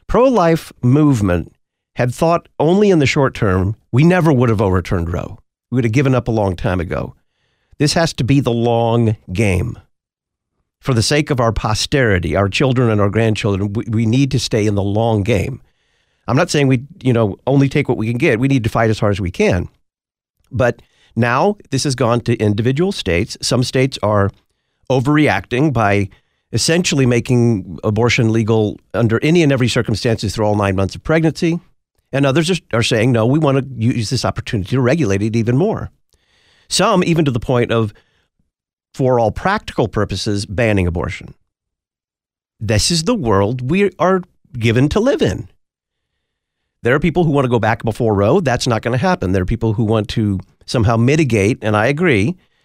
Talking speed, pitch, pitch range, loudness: 185 wpm, 115 Hz, 105-135 Hz, -16 LUFS